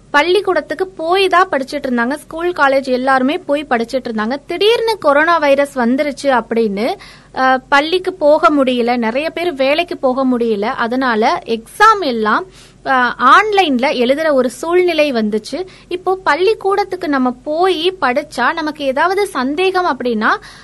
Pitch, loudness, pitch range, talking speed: 285 Hz, -14 LUFS, 255-355 Hz, 120 wpm